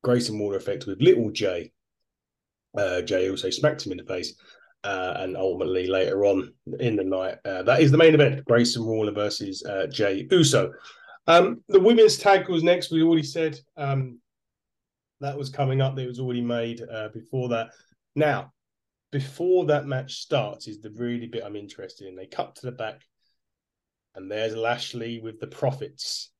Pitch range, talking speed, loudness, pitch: 110-145 Hz, 175 wpm, -24 LUFS, 120 Hz